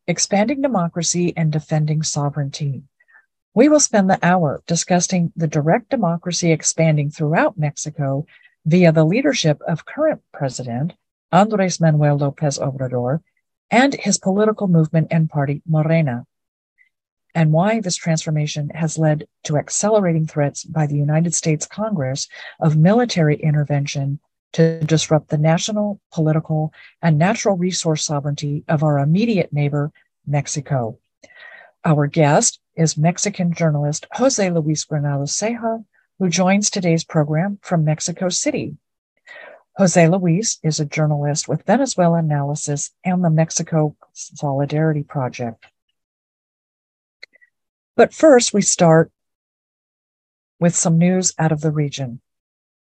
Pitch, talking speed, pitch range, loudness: 160 Hz, 120 wpm, 150-180 Hz, -18 LUFS